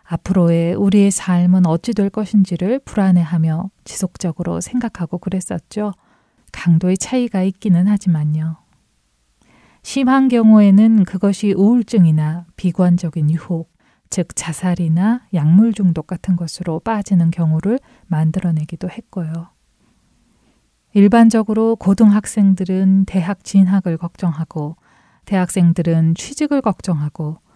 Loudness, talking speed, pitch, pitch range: -16 LUFS, 280 characters per minute, 185 Hz, 170-205 Hz